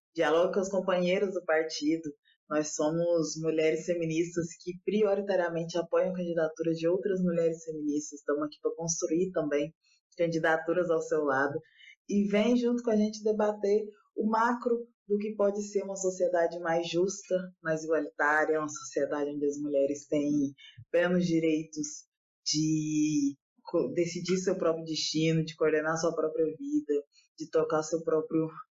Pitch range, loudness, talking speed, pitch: 155-185 Hz, -30 LUFS, 140 wpm, 165 Hz